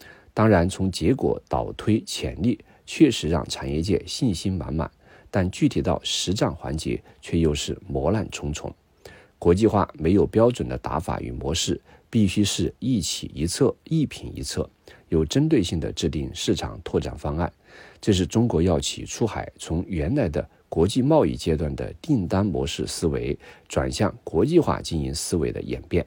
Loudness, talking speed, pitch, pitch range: -24 LUFS, 250 characters per minute, 80 Hz, 70-95 Hz